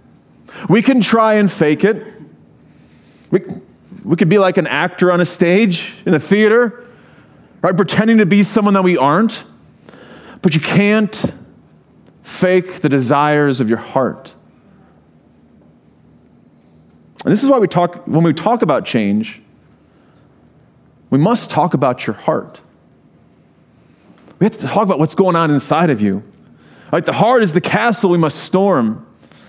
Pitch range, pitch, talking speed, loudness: 150-210 Hz, 185 Hz, 150 wpm, -14 LUFS